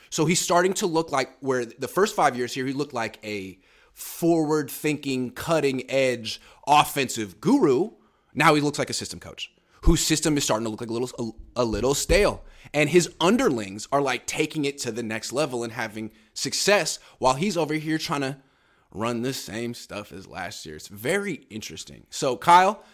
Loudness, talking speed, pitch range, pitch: -24 LUFS, 195 wpm, 110-155 Hz, 135 Hz